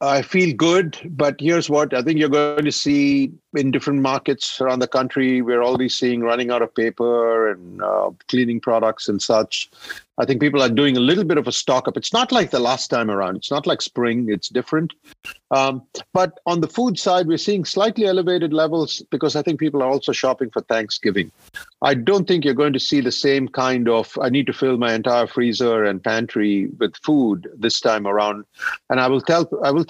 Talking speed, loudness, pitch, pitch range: 215 wpm, -19 LUFS, 135 Hz, 120-160 Hz